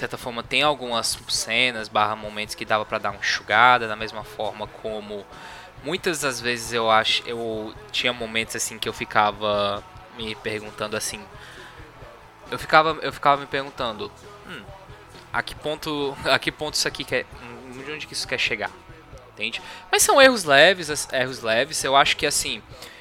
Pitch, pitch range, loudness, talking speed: 115 Hz, 110-140 Hz, -22 LUFS, 170 wpm